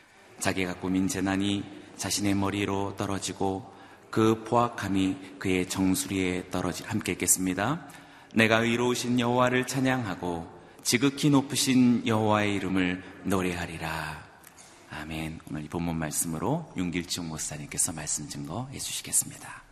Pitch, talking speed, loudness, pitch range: 95 Hz, 310 characters per minute, -28 LUFS, 90-120 Hz